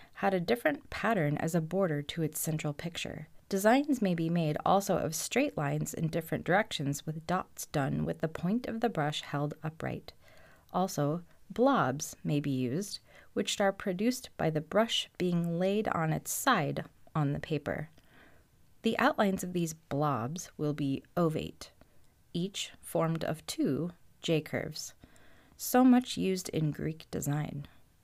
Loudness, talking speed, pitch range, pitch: -32 LUFS, 155 wpm, 150-195 Hz, 165 Hz